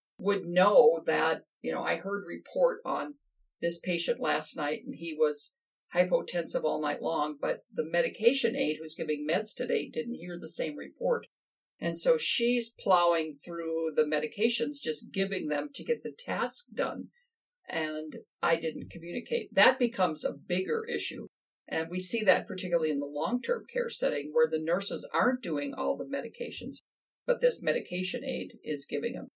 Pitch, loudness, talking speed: 200 Hz, -30 LUFS, 170 wpm